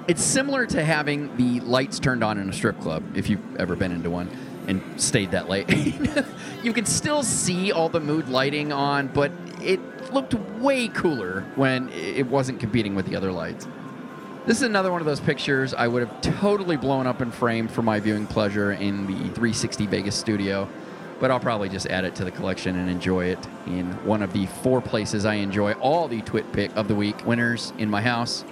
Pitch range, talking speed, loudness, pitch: 105-155 Hz, 205 wpm, -24 LUFS, 120 Hz